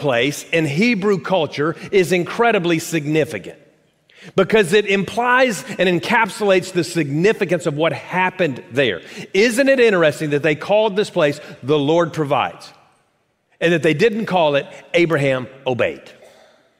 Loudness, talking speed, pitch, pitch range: -17 LUFS, 130 wpm, 175 Hz, 150-205 Hz